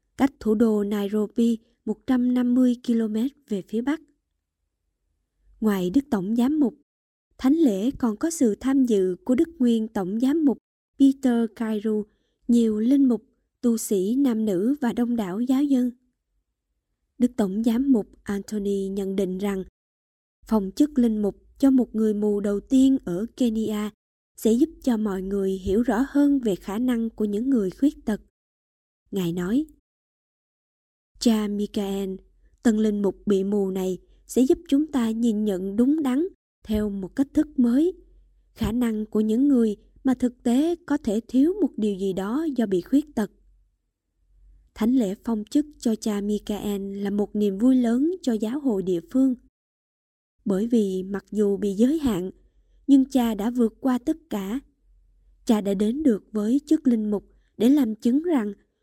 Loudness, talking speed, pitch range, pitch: -24 LUFS, 165 wpm, 205-260 Hz, 225 Hz